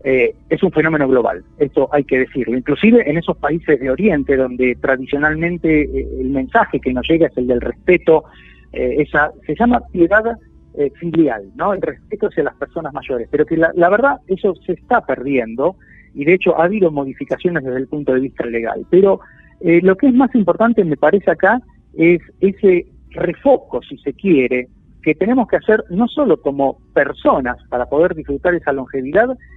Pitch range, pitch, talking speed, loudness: 135-190 Hz, 160 Hz, 185 wpm, -16 LUFS